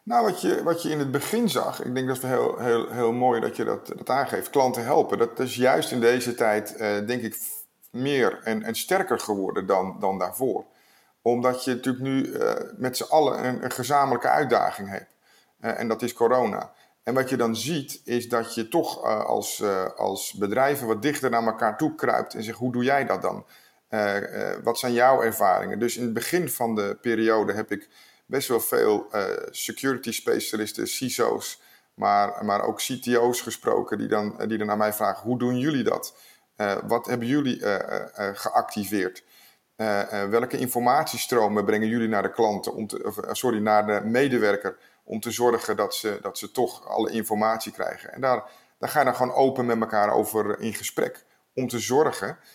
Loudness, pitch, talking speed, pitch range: -25 LUFS, 120 Hz, 195 wpm, 110-130 Hz